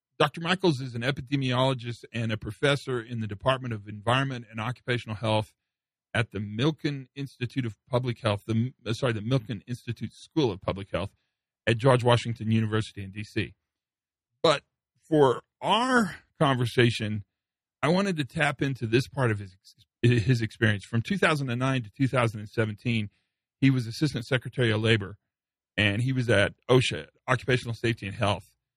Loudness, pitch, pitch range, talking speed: -27 LUFS, 120 Hz, 110-130 Hz, 150 wpm